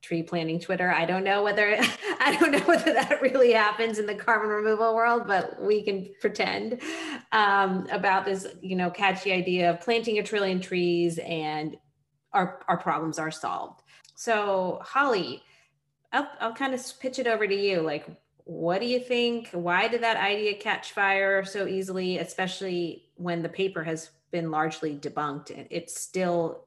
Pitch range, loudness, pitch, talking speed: 170-220 Hz, -26 LUFS, 195 Hz, 170 wpm